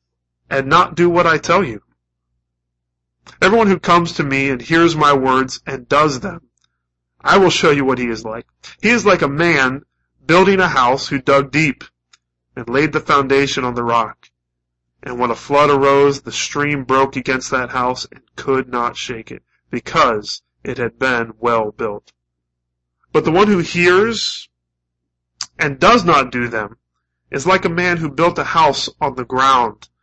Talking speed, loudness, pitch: 175 wpm, -15 LUFS, 130 Hz